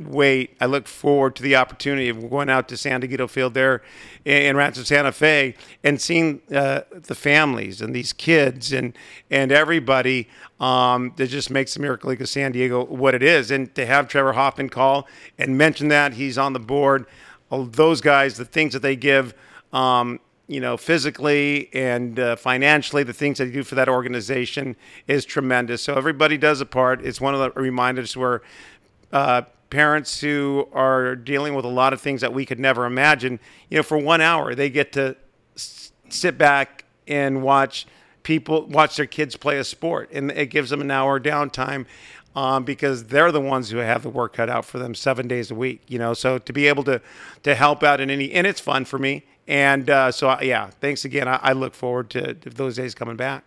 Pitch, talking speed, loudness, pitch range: 135 Hz, 205 wpm, -20 LUFS, 130-145 Hz